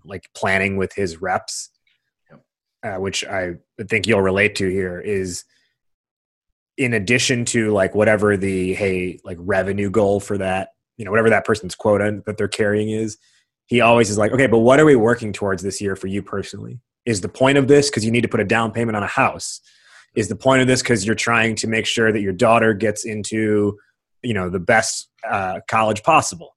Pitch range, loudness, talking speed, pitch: 100-115 Hz, -18 LUFS, 205 wpm, 110 Hz